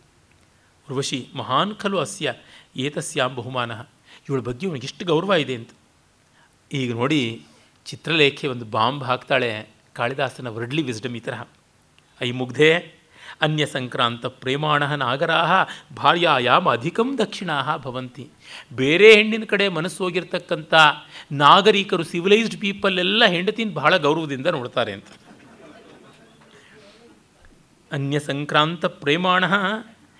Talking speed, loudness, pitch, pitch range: 85 wpm, -20 LUFS, 150 Hz, 130-180 Hz